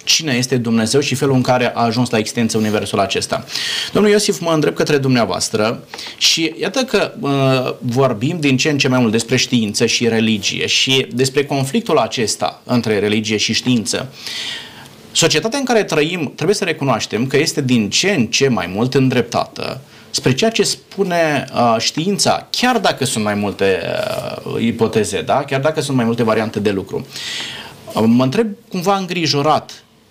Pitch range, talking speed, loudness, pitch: 115-160 Hz, 170 wpm, -16 LUFS, 130 Hz